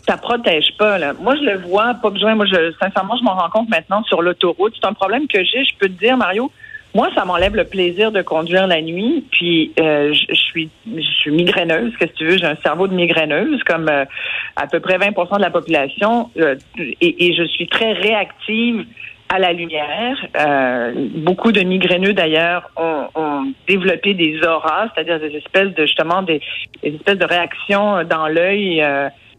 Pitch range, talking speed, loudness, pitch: 160-205 Hz, 200 wpm, -16 LUFS, 180 Hz